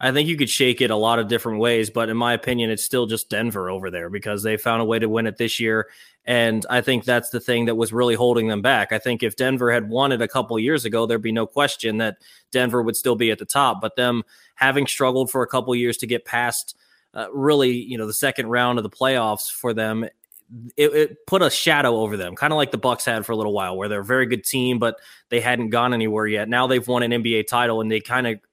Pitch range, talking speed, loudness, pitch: 110-125 Hz, 275 wpm, -21 LUFS, 120 Hz